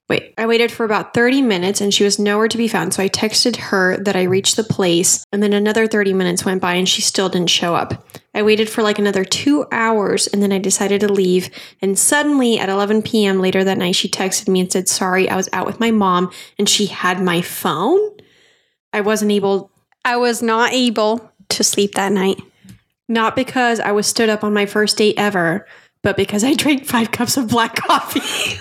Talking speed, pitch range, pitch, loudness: 220 wpm, 190-230 Hz, 205 Hz, -16 LUFS